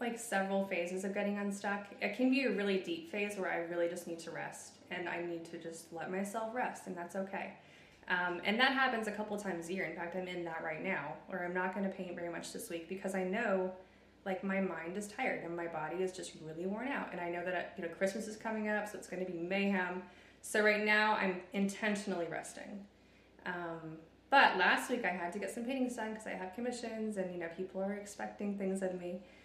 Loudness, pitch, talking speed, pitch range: -37 LUFS, 190 Hz, 240 wpm, 175-210 Hz